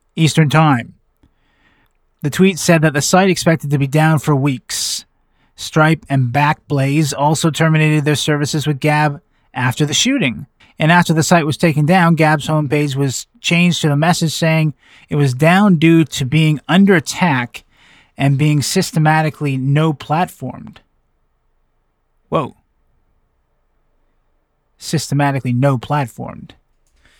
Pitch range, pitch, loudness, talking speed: 145-165 Hz, 155 Hz, -15 LUFS, 125 wpm